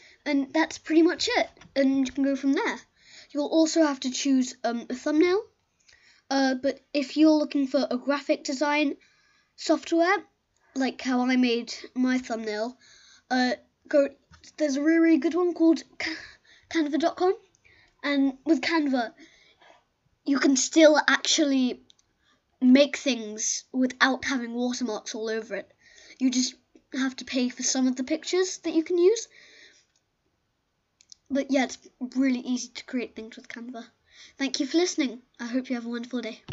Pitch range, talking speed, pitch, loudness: 255-320 Hz, 155 wpm, 275 Hz, -25 LUFS